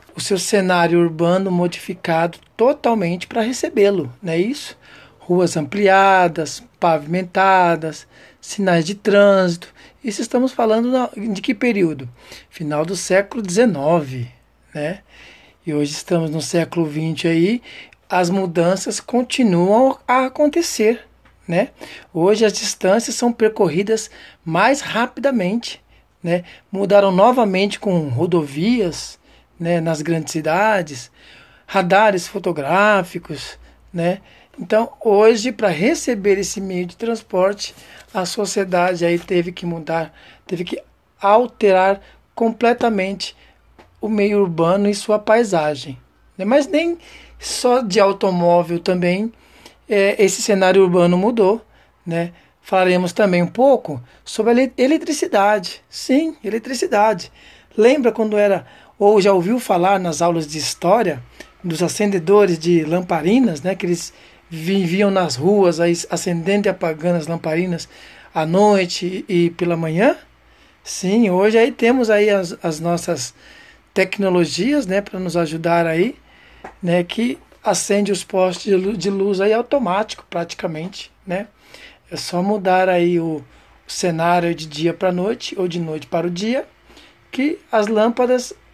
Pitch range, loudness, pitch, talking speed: 170-220 Hz, -18 LUFS, 190 Hz, 125 wpm